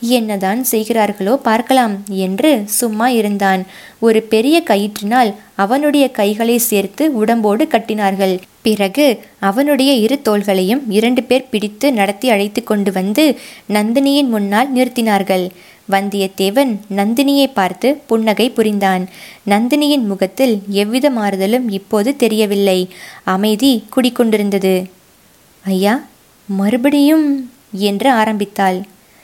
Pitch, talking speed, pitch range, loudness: 215 Hz, 90 wpm, 200-255 Hz, -14 LUFS